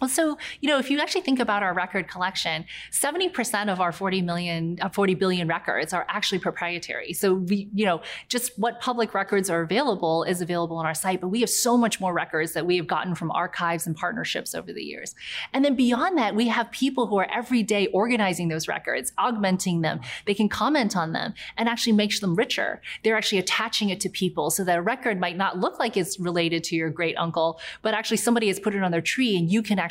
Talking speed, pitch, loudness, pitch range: 235 wpm, 195 Hz, -25 LUFS, 175-230 Hz